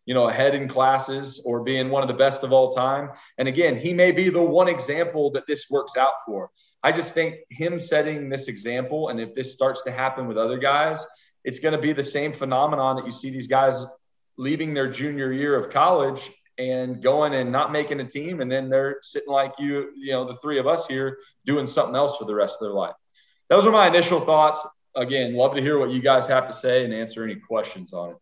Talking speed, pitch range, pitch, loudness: 235 wpm, 130-150 Hz, 135 Hz, -22 LUFS